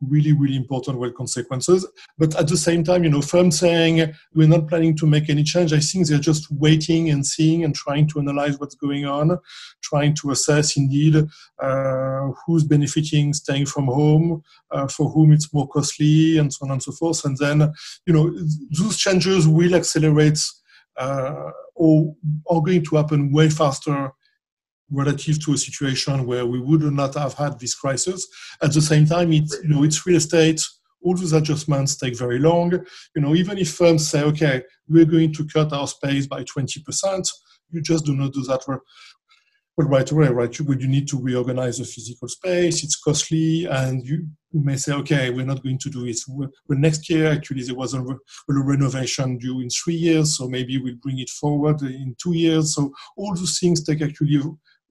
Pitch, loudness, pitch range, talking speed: 150 Hz, -20 LUFS, 140-160 Hz, 195 wpm